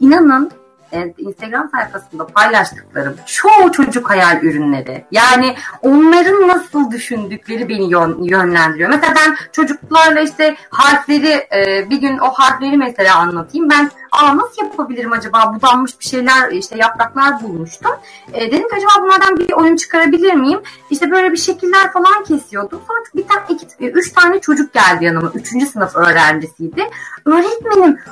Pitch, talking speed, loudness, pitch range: 280 Hz, 135 wpm, -12 LUFS, 210-330 Hz